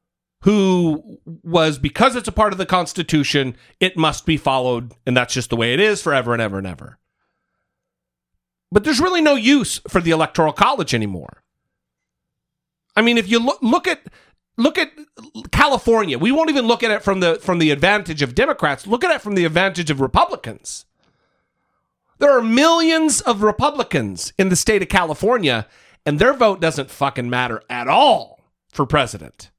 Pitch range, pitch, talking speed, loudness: 145-235 Hz, 185 Hz, 175 wpm, -17 LUFS